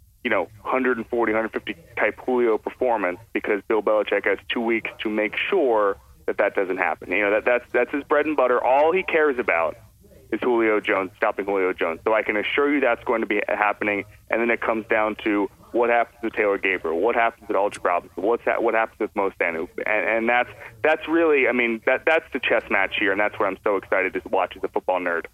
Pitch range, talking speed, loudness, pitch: 110-125 Hz, 225 wpm, -22 LUFS, 115 Hz